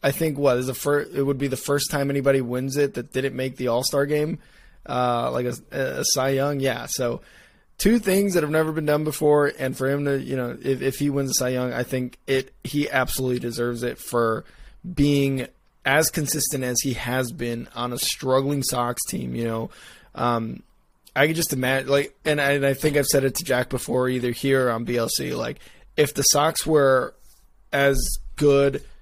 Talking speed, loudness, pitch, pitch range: 210 wpm, -23 LUFS, 135 Hz, 125-145 Hz